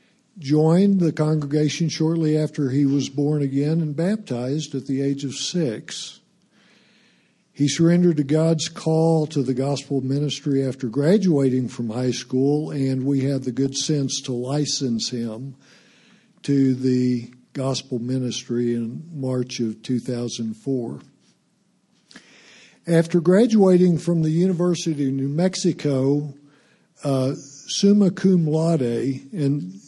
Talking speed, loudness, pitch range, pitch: 120 wpm, -21 LUFS, 130-160 Hz, 140 Hz